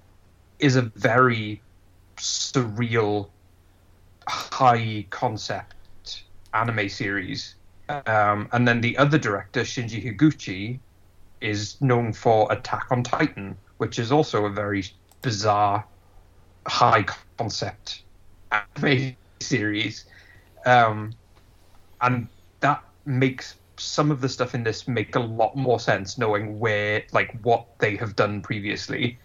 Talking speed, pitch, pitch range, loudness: 115 wpm, 105 Hz, 95-125 Hz, -24 LUFS